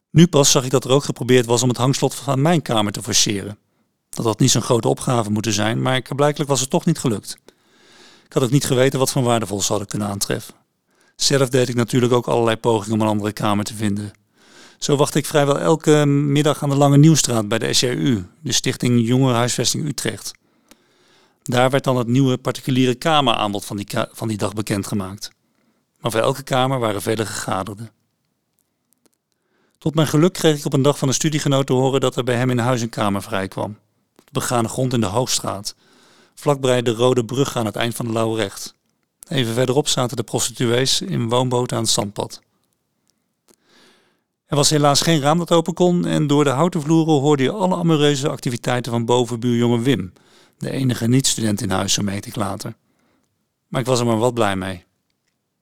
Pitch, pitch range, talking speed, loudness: 125 Hz, 110-140 Hz, 195 wpm, -19 LUFS